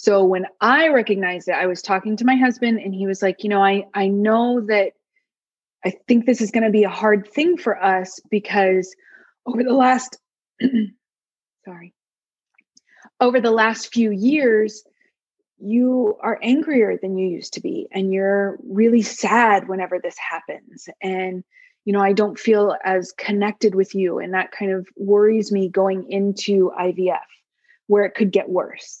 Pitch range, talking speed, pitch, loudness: 190-230 Hz, 170 wpm, 205 Hz, -19 LUFS